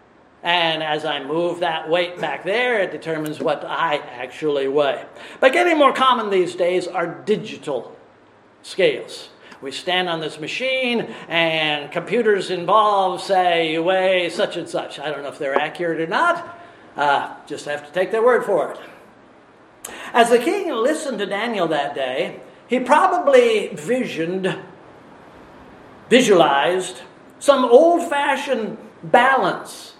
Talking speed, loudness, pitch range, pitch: 140 wpm, -19 LUFS, 165-260 Hz, 185 Hz